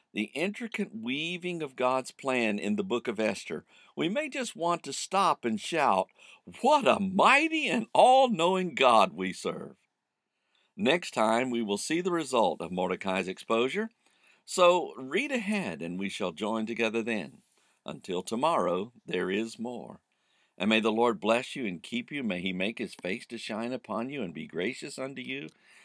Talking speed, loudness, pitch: 175 wpm, -29 LUFS, 125 Hz